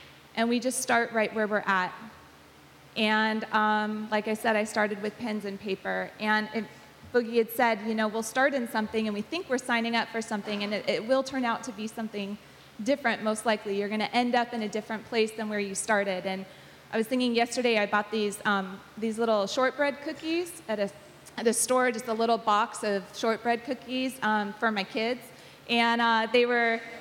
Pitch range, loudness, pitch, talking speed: 210-235 Hz, -28 LUFS, 220 Hz, 210 wpm